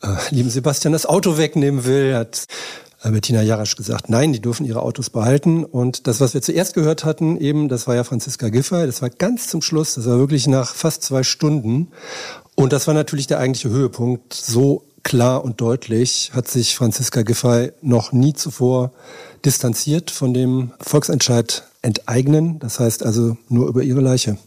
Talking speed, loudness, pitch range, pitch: 175 wpm, -18 LUFS, 120-150 Hz, 130 Hz